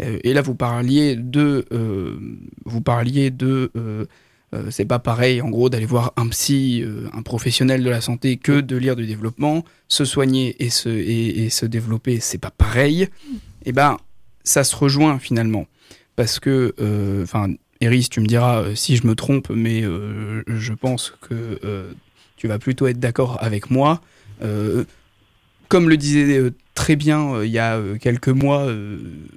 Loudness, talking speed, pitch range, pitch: -19 LUFS, 180 wpm, 110-130 Hz, 120 Hz